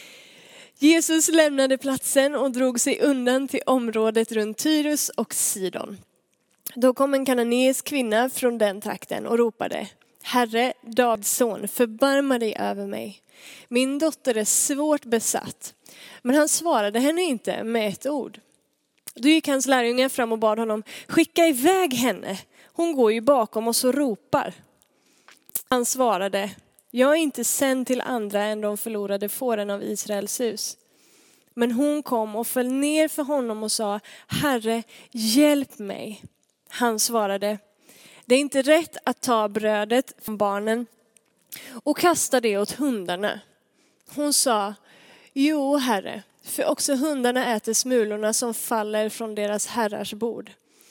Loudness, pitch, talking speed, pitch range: -23 LUFS, 245 Hz, 140 wpm, 215-275 Hz